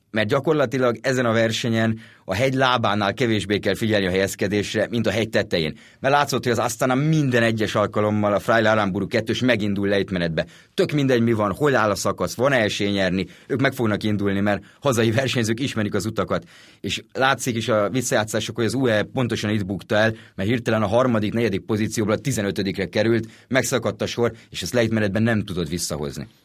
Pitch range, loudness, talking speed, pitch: 105-120 Hz, -22 LUFS, 190 wpm, 110 Hz